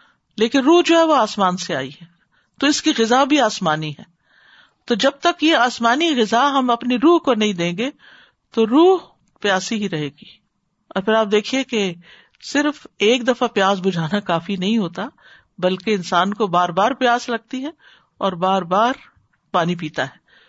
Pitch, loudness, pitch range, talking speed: 220 Hz, -18 LUFS, 185-265 Hz, 180 wpm